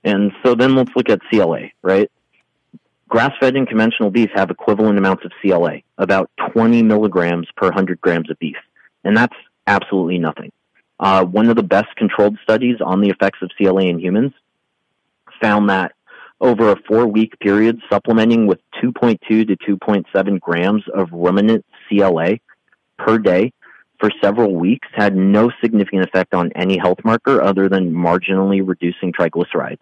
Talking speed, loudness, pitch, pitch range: 155 wpm, -16 LUFS, 100 Hz, 95-110 Hz